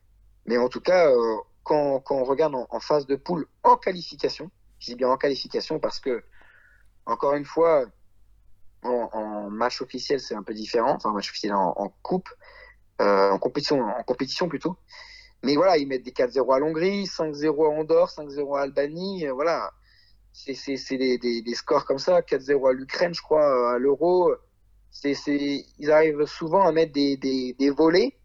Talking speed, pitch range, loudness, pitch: 185 wpm, 125-165 Hz, -24 LUFS, 140 Hz